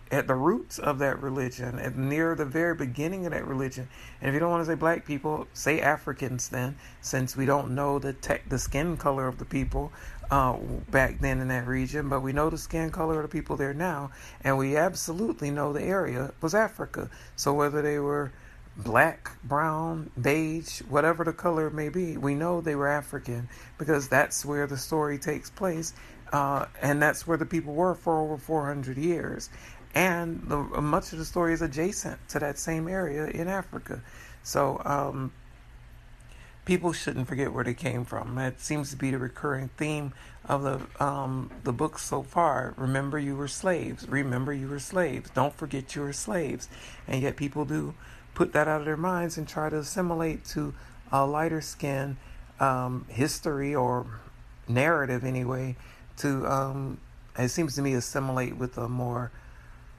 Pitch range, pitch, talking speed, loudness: 130-155 Hz, 145 Hz, 180 wpm, -29 LUFS